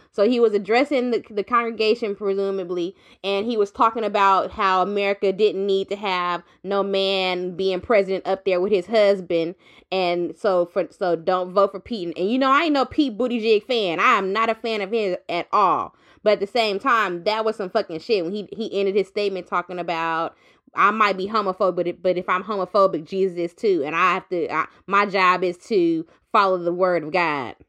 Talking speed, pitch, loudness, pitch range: 210 wpm, 195 Hz, -21 LUFS, 180-215 Hz